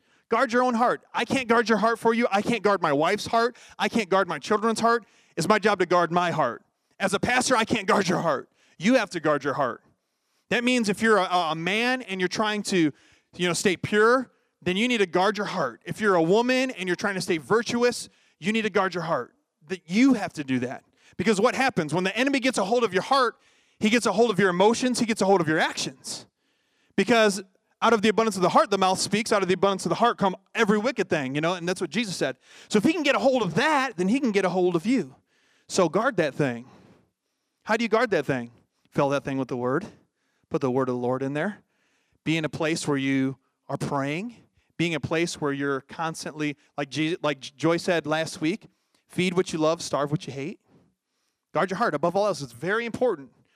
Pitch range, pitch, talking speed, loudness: 160-230 Hz, 195 Hz, 250 wpm, -24 LUFS